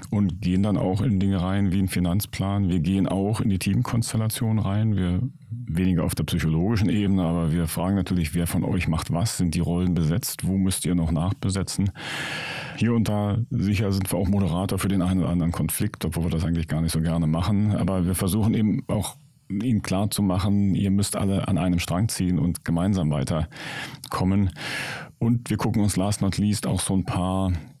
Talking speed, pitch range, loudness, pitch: 205 wpm, 90-105 Hz, -24 LUFS, 95 Hz